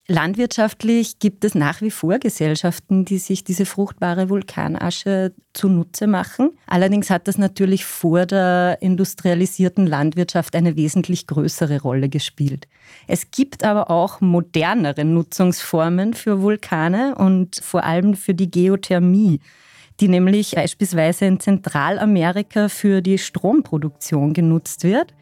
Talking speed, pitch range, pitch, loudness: 120 wpm, 170-200 Hz, 185 Hz, -18 LUFS